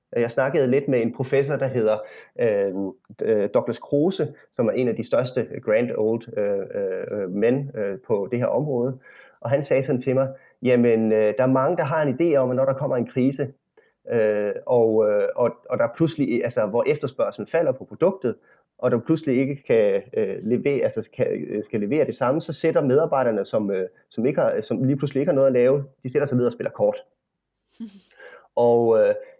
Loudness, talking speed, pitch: -22 LUFS, 205 wpm, 140 Hz